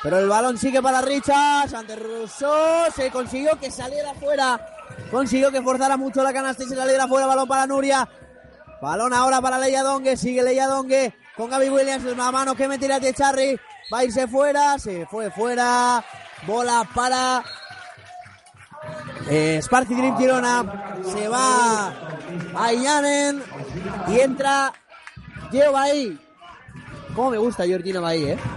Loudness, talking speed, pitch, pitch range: -21 LUFS, 145 wpm, 260 Hz, 230-270 Hz